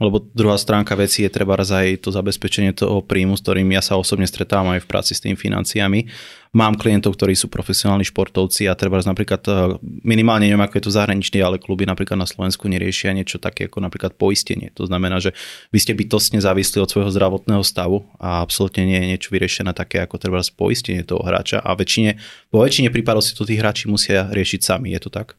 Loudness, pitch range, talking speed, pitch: -18 LUFS, 95-105 Hz, 205 wpm, 100 Hz